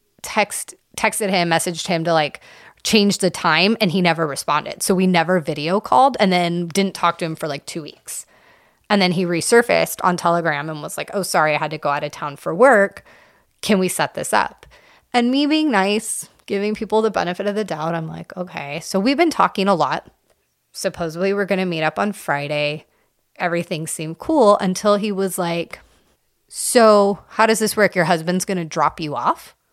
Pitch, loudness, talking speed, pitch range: 185 Hz, -19 LUFS, 205 wpm, 165-205 Hz